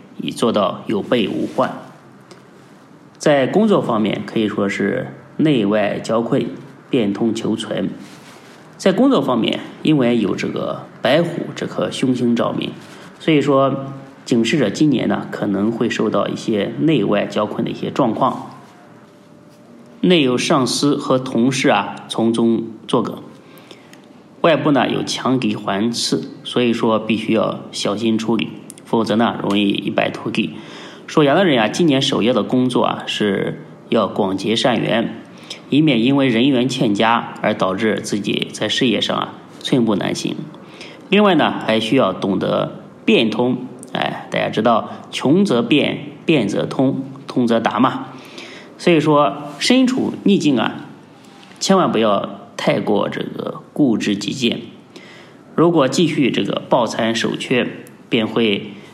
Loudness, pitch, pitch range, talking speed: -18 LUFS, 120 Hz, 110-135 Hz, 210 characters per minute